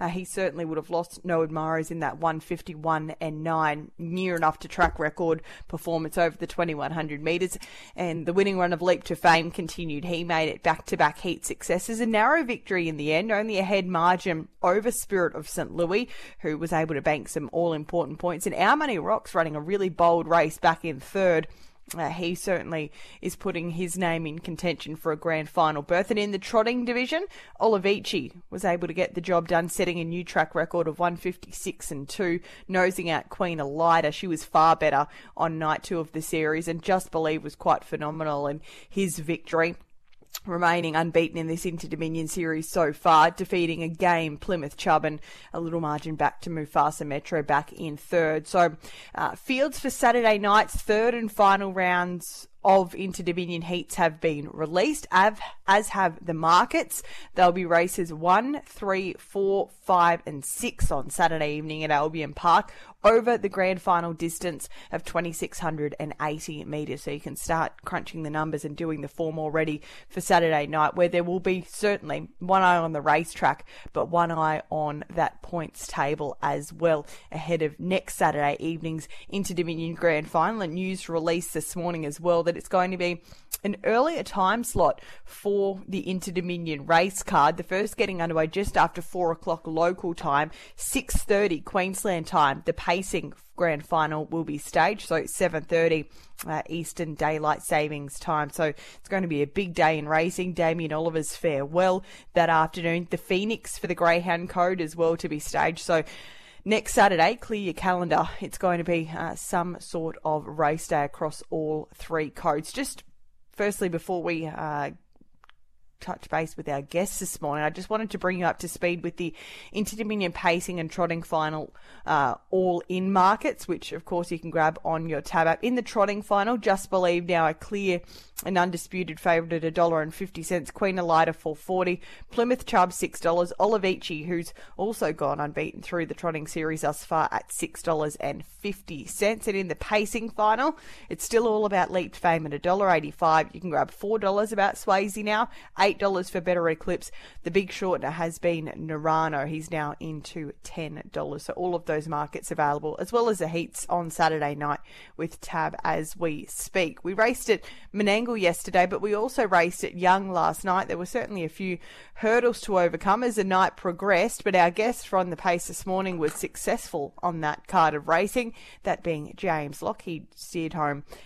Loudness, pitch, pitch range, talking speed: -26 LUFS, 170 Hz, 160-190 Hz, 185 wpm